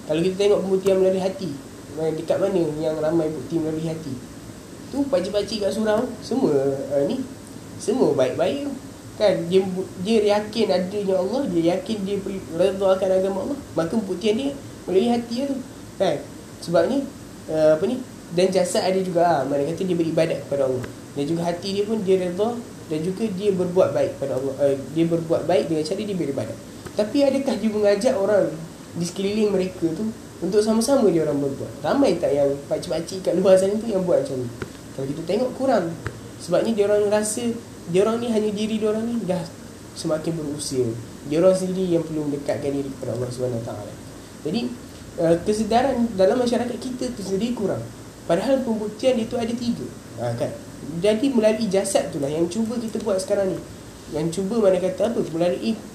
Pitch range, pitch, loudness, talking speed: 155-215 Hz, 190 Hz, -23 LUFS, 180 wpm